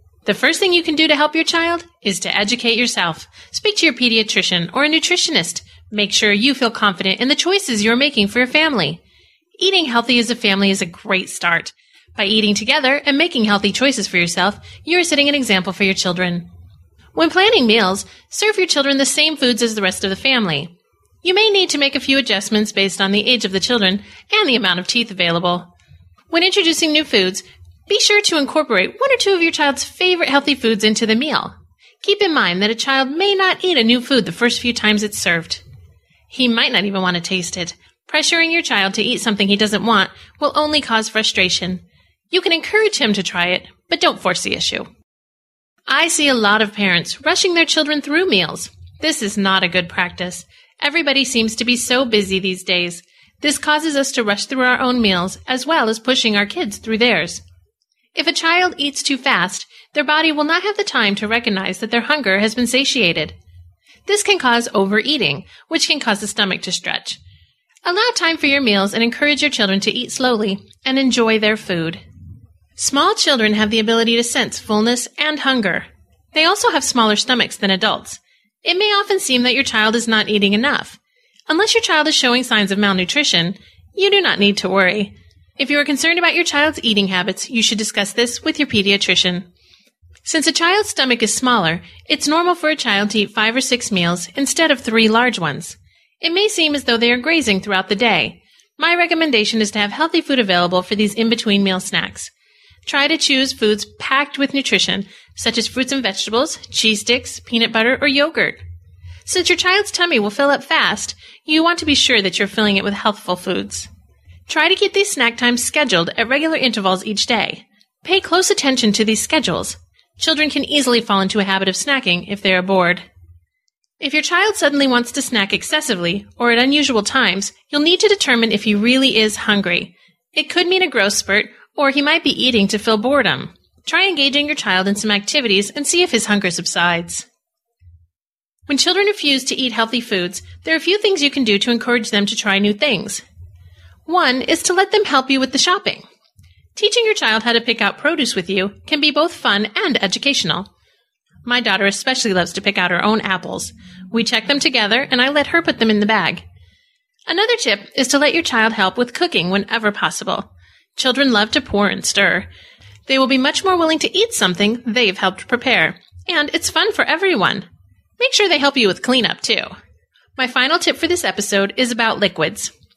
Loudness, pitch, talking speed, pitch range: -15 LUFS, 235 Hz, 210 wpm, 200-300 Hz